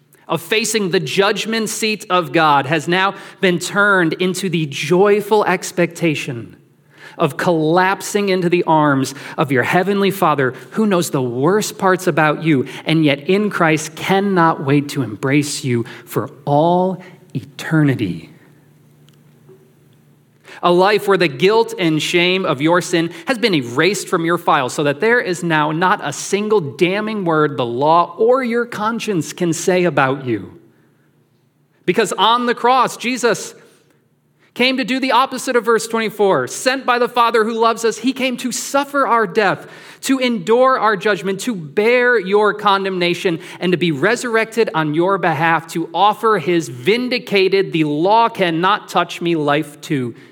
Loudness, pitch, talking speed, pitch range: -16 LUFS, 180 Hz, 155 wpm, 155-215 Hz